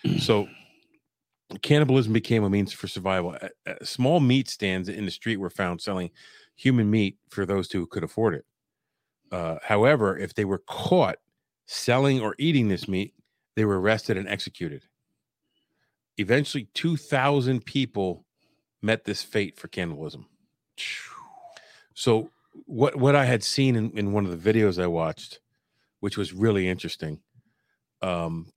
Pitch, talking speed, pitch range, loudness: 105 Hz, 145 wpm, 95-130 Hz, -25 LUFS